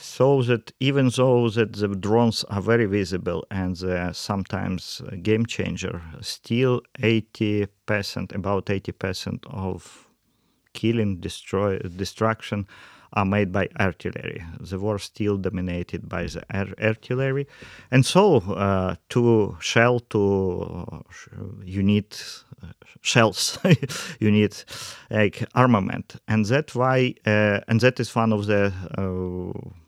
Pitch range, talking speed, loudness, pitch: 95-115 Hz, 125 wpm, -23 LUFS, 105 Hz